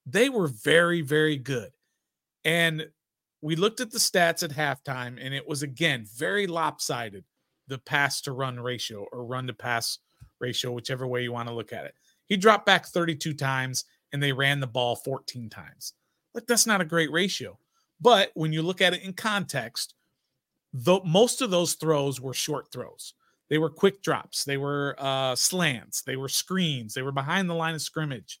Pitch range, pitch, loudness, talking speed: 130-175 Hz, 150 Hz, -26 LUFS, 190 wpm